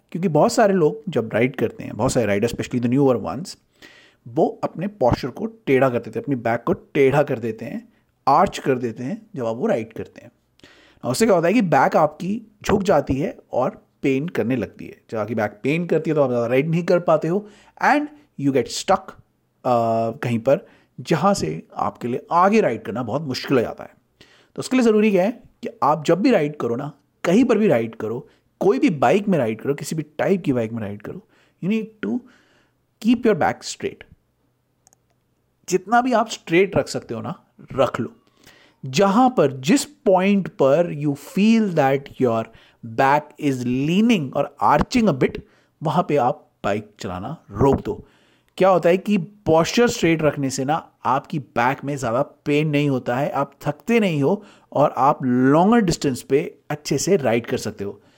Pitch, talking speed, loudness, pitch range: 150 Hz, 195 wpm, -20 LUFS, 135-195 Hz